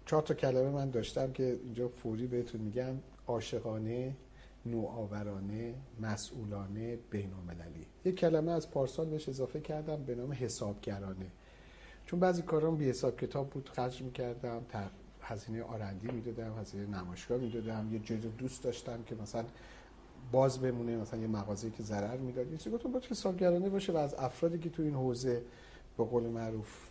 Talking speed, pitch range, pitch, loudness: 155 wpm, 110-135 Hz, 120 Hz, -37 LUFS